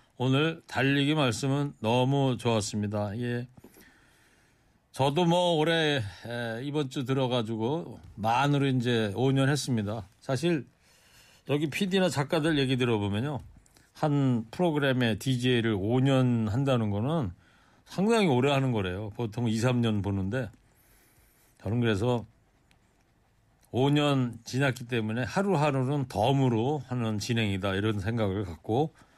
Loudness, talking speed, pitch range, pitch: -28 LUFS, 250 characters per minute, 110-140 Hz, 125 Hz